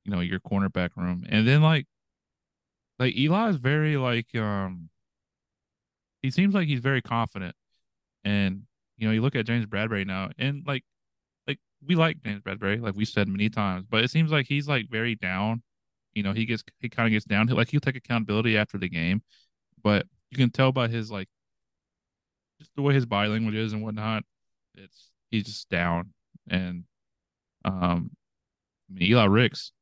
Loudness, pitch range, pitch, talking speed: -26 LUFS, 95-130 Hz, 110 Hz, 185 wpm